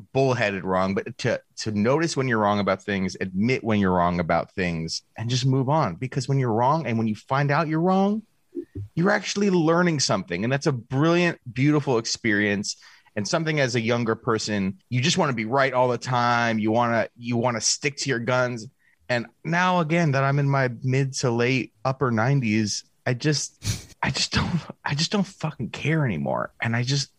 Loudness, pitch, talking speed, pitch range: -24 LUFS, 130 Hz, 205 wpm, 110-150 Hz